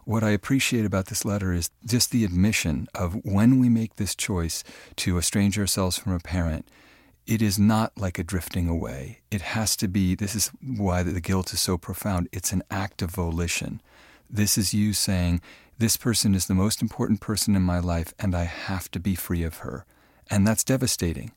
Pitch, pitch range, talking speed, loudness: 95 Hz, 90-110 Hz, 200 wpm, -25 LUFS